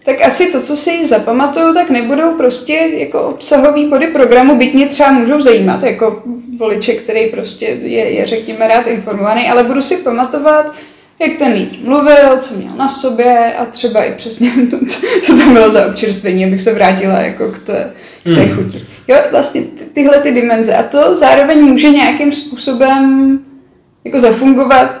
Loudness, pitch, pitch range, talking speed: -10 LUFS, 265 Hz, 230-290 Hz, 170 wpm